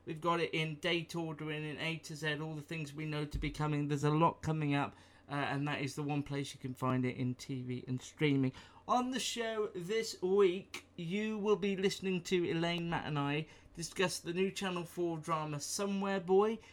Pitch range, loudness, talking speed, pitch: 145-185 Hz, -36 LUFS, 215 wpm, 160 Hz